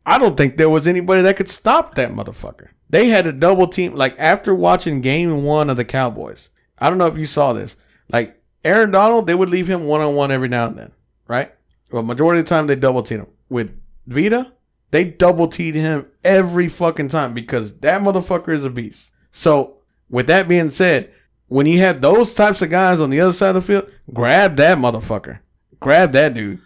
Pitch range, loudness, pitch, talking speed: 135-185 Hz, -16 LUFS, 160 Hz, 205 wpm